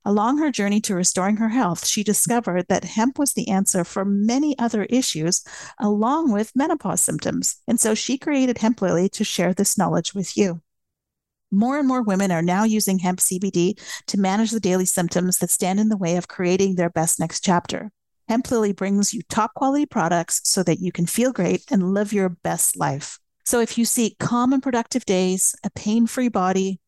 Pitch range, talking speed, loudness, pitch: 185-235 Hz, 200 wpm, -21 LUFS, 205 Hz